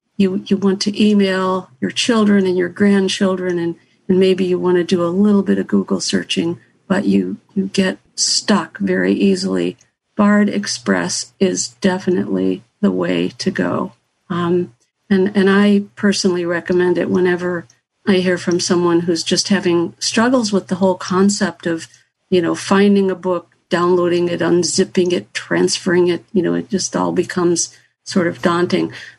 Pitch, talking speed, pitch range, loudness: 180 Hz, 160 wpm, 170-195 Hz, -17 LUFS